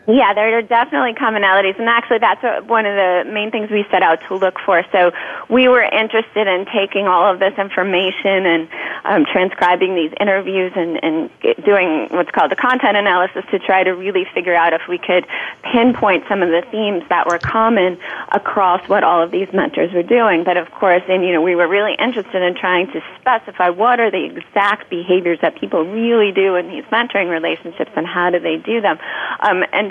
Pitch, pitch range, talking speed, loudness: 190 Hz, 180-220 Hz, 205 wpm, -15 LUFS